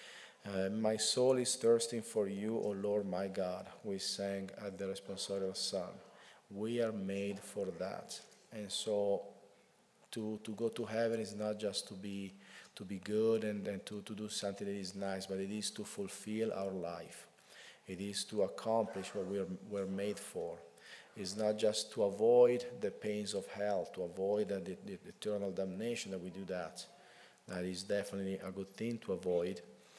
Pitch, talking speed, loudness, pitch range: 100 Hz, 185 wpm, -38 LUFS, 95-110 Hz